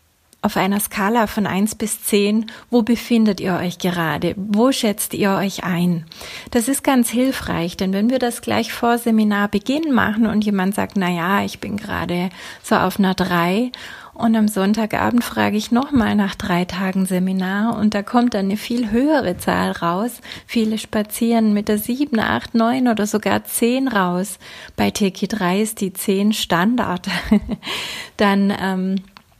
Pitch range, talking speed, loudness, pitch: 190-230 Hz, 165 wpm, -19 LUFS, 210 Hz